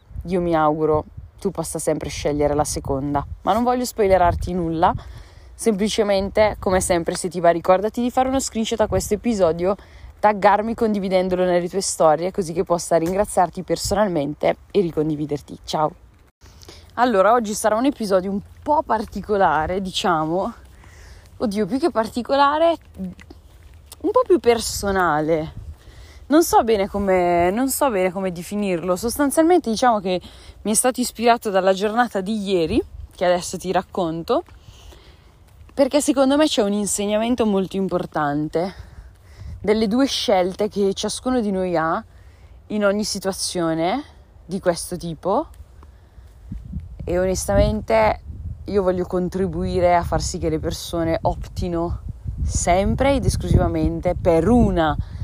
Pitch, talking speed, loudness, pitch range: 185 Hz, 130 wpm, -20 LUFS, 165-215 Hz